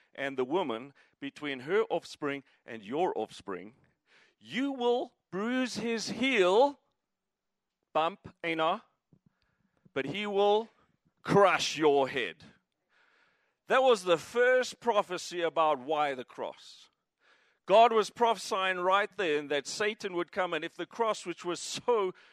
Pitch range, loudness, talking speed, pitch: 160-235 Hz, -30 LUFS, 130 wpm, 190 Hz